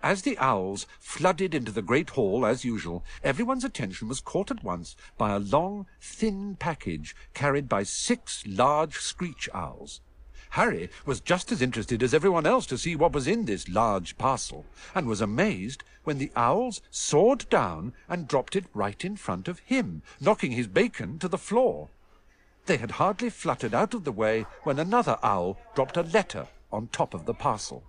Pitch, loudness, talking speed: 155 Hz, -28 LUFS, 180 wpm